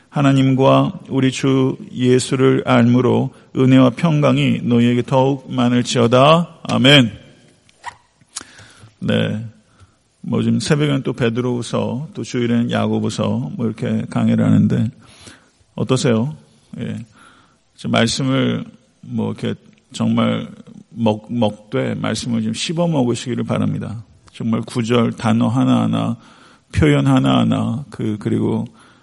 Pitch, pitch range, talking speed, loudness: 120 Hz, 115-130 Hz, 240 characters per minute, -17 LUFS